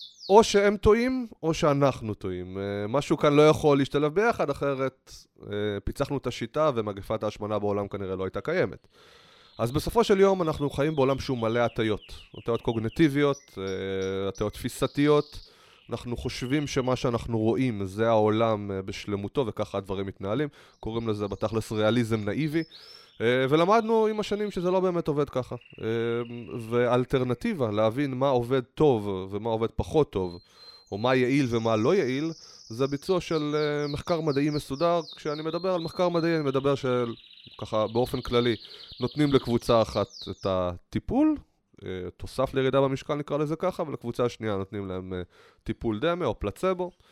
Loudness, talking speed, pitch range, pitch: -27 LUFS, 140 wpm, 110-150 Hz, 125 Hz